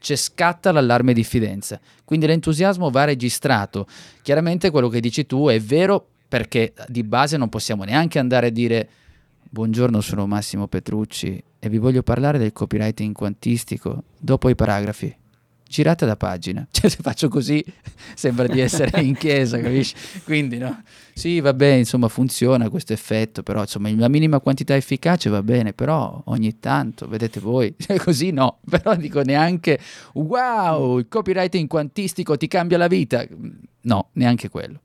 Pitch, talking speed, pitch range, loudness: 130 Hz, 155 wpm, 110-155 Hz, -20 LUFS